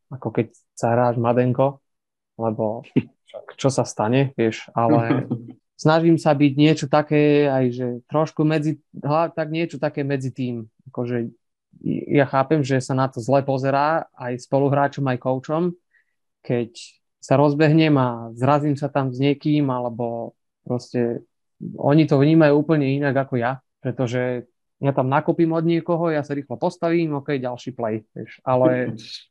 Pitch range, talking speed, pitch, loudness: 125-150 Hz, 145 wpm, 135 Hz, -21 LUFS